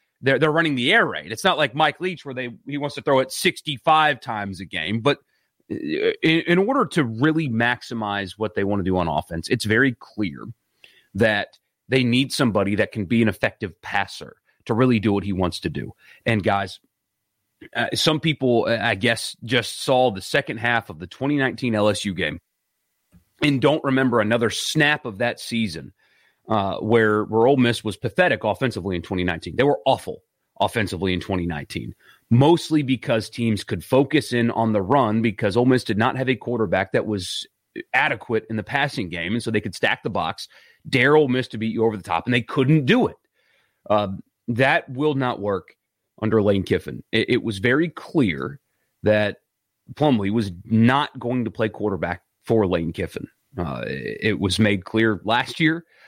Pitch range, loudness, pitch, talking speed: 105-135 Hz, -21 LUFS, 115 Hz, 185 wpm